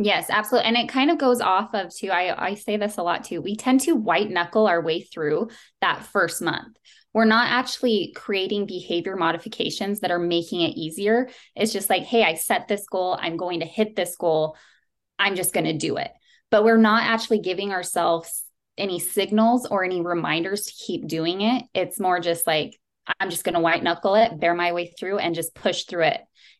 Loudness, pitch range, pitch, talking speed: -23 LUFS, 170-220 Hz, 195 Hz, 210 wpm